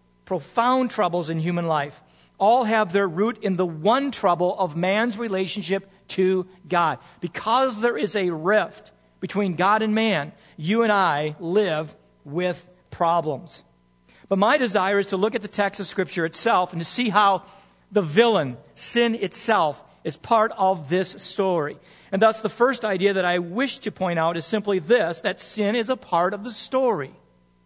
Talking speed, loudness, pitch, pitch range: 175 wpm, -23 LUFS, 195 Hz, 175-220 Hz